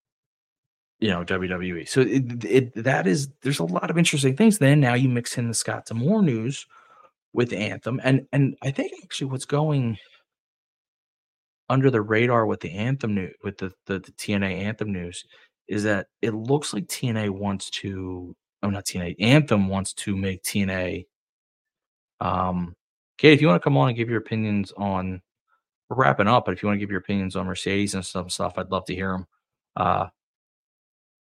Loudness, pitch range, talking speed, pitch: -24 LUFS, 95-130 Hz, 190 wpm, 105 Hz